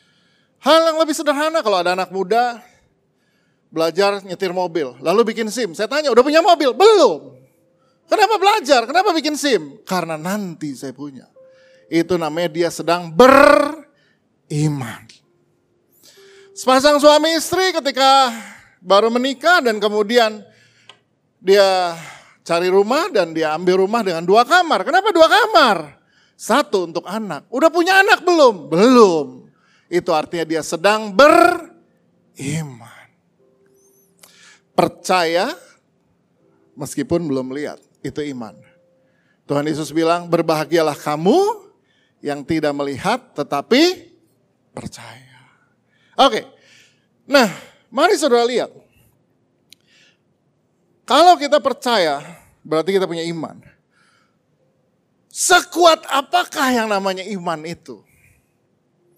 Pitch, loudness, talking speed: 200 Hz, -16 LUFS, 105 wpm